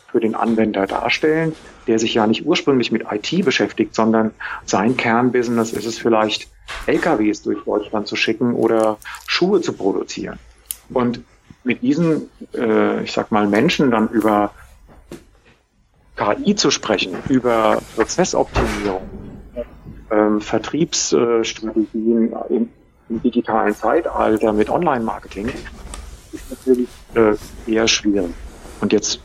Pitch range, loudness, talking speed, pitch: 105-120 Hz, -18 LUFS, 120 wpm, 110 Hz